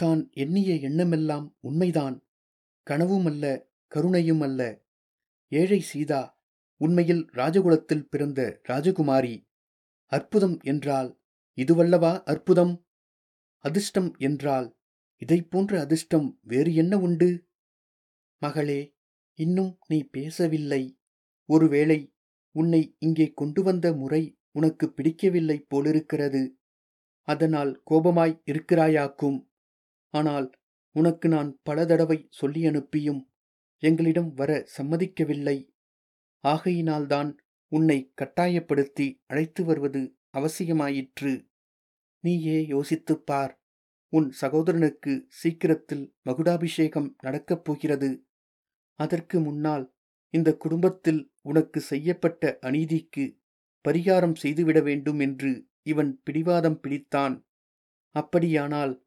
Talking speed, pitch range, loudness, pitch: 85 wpm, 140-165 Hz, -26 LUFS, 155 Hz